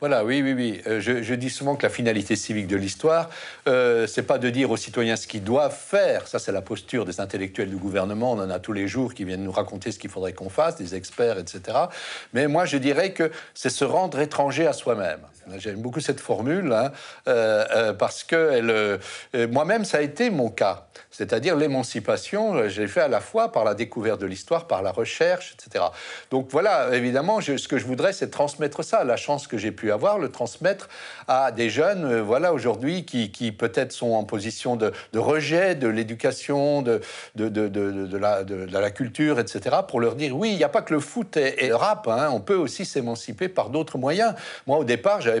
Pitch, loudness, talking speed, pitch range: 125 Hz, -24 LUFS, 225 wpm, 110-155 Hz